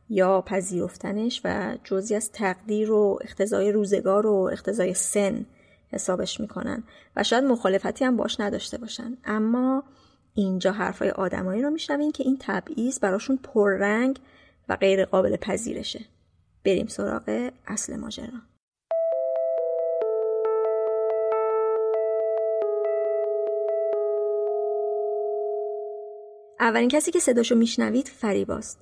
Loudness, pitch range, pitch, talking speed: -25 LUFS, 195-235 Hz, 215 Hz, 95 wpm